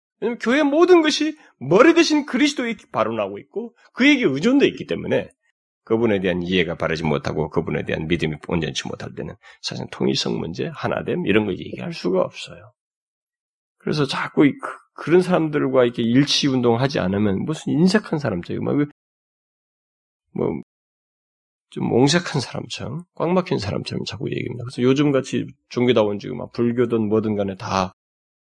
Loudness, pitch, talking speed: -20 LUFS, 135 Hz, 340 characters per minute